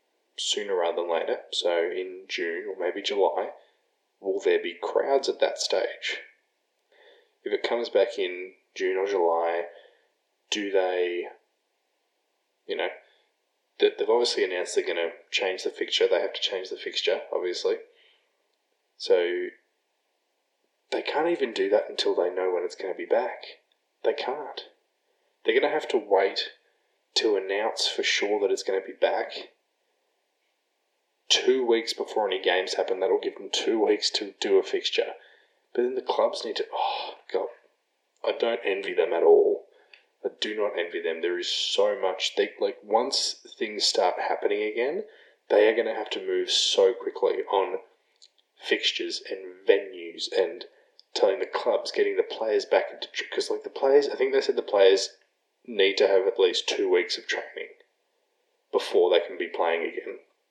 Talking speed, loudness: 170 wpm, -26 LUFS